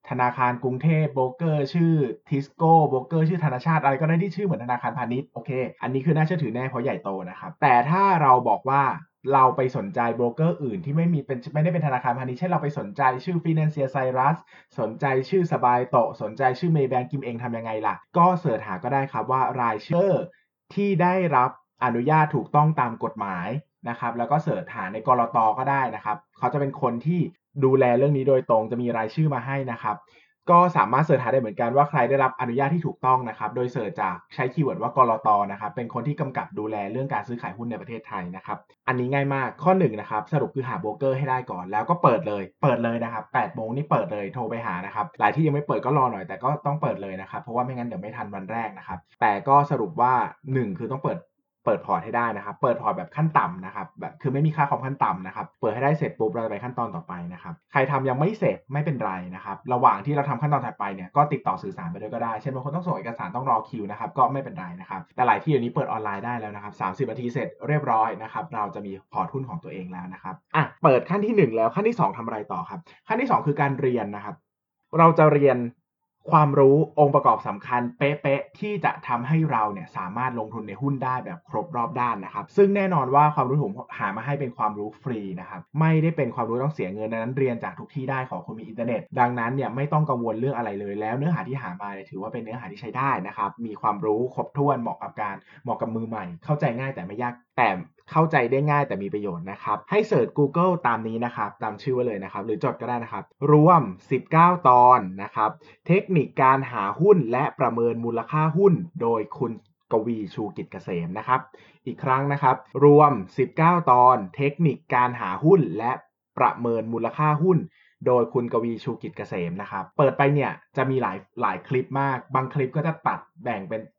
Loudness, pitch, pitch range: -24 LUFS, 135 Hz, 120-150 Hz